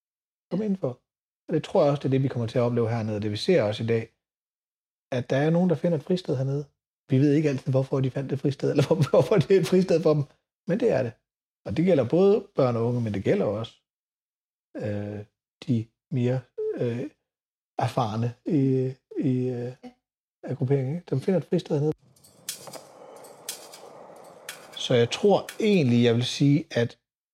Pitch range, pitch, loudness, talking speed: 120-155 Hz, 135 Hz, -25 LUFS, 190 wpm